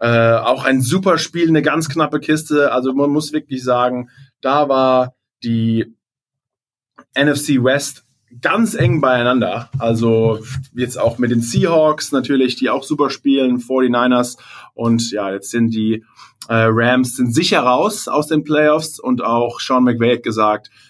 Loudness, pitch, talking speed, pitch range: -16 LUFS, 130 Hz, 150 wpm, 120-145 Hz